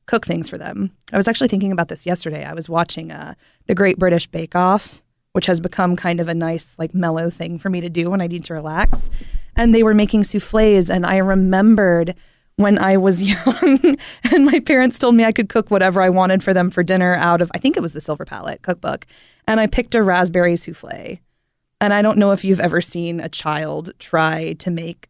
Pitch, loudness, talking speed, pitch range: 185 Hz, -17 LUFS, 225 wpm, 170-210 Hz